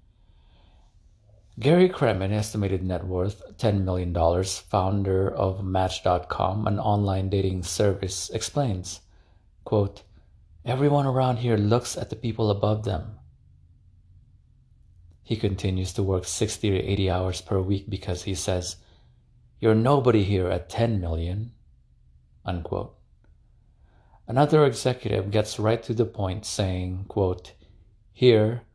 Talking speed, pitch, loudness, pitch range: 115 wpm, 95 Hz, -25 LUFS, 90-110 Hz